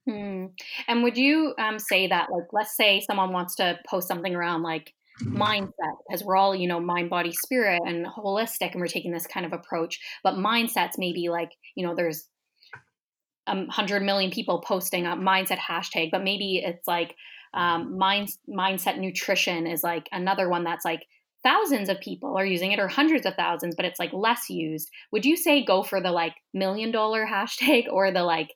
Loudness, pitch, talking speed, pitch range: -25 LUFS, 190 Hz, 195 wpm, 175-205 Hz